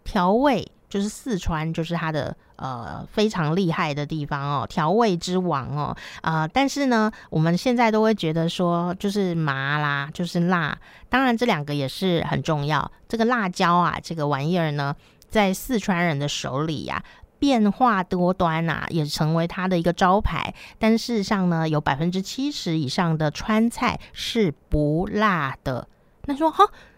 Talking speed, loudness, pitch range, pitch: 250 characters per minute, -23 LUFS, 155-215 Hz, 175 Hz